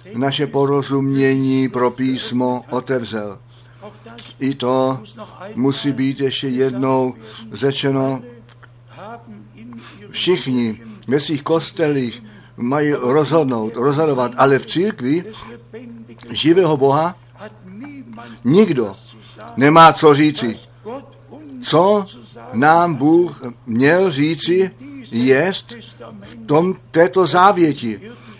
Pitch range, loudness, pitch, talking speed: 120-145 Hz, -16 LUFS, 130 Hz, 80 wpm